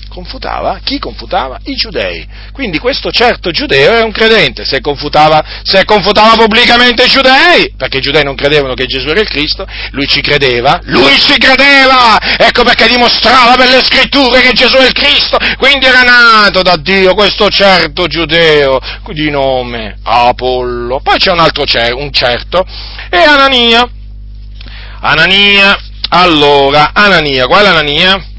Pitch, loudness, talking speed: 190 Hz, -6 LUFS, 155 wpm